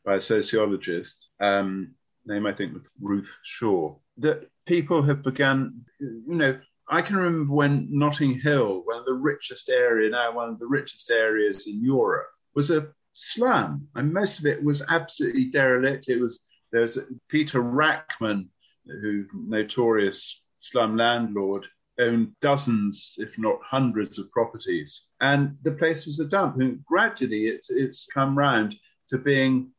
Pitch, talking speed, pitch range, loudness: 130 Hz, 155 wpm, 110-145 Hz, -25 LUFS